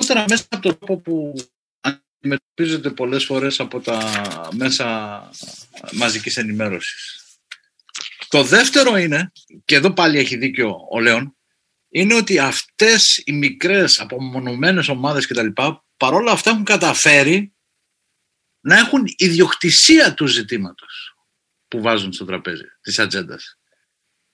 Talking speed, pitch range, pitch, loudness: 115 wpm, 130-205 Hz, 150 Hz, -16 LUFS